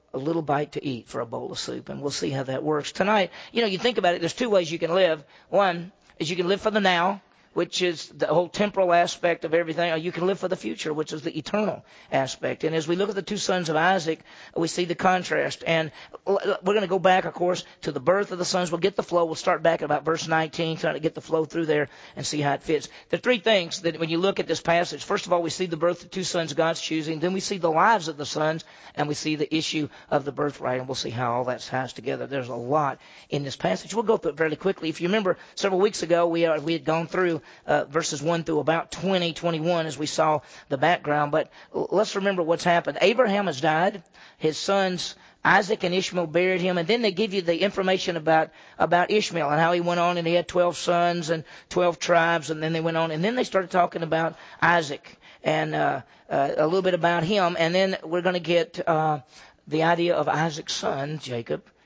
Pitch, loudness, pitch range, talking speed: 170 Hz, -25 LUFS, 160-185 Hz, 255 wpm